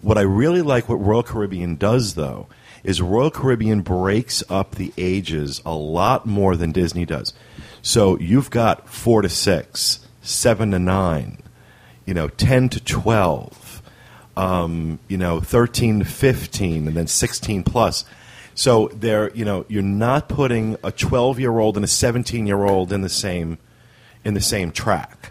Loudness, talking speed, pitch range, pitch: -19 LUFS, 165 wpm, 90-120 Hz, 105 Hz